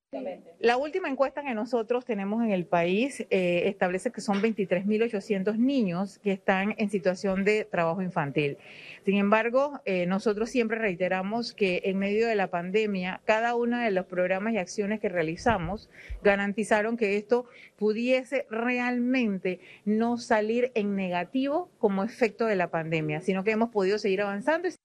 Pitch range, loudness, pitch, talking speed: 190-235 Hz, -27 LUFS, 210 Hz, 155 wpm